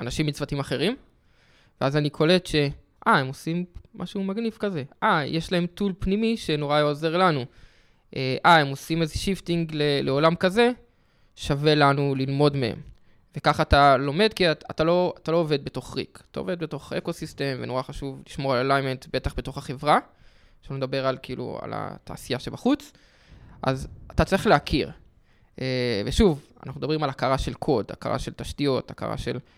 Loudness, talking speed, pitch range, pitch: -25 LUFS, 160 wpm, 135-175 Hz, 150 Hz